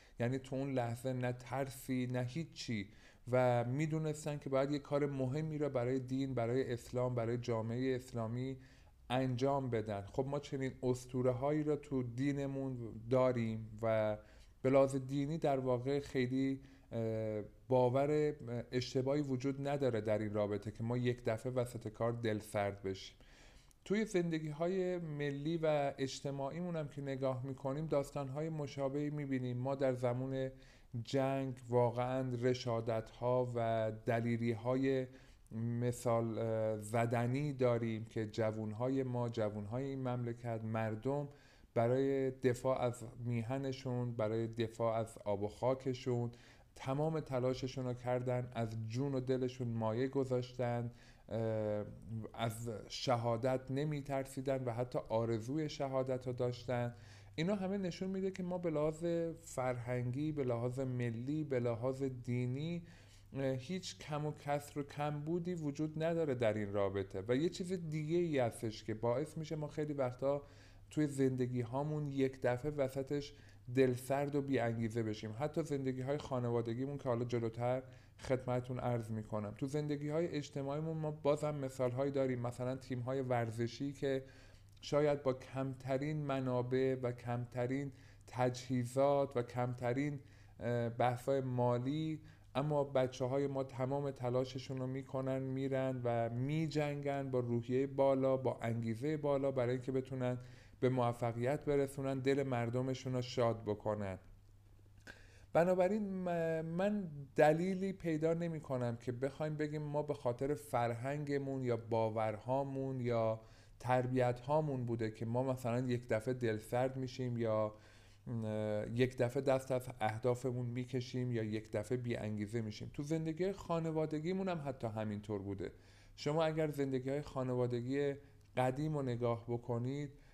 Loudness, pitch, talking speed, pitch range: -38 LUFS, 130 Hz, 135 wpm, 120-140 Hz